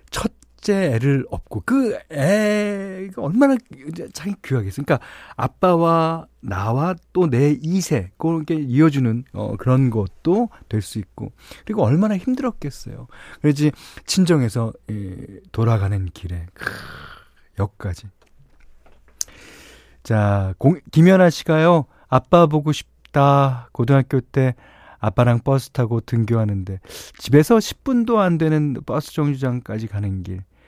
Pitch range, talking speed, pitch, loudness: 110-165 Hz, 235 characters per minute, 135 Hz, -19 LUFS